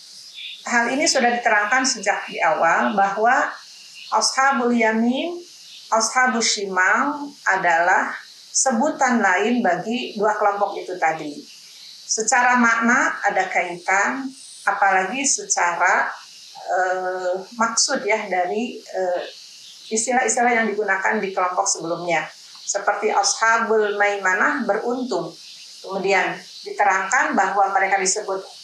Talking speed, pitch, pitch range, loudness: 95 wpm, 220 Hz, 195-255 Hz, -19 LUFS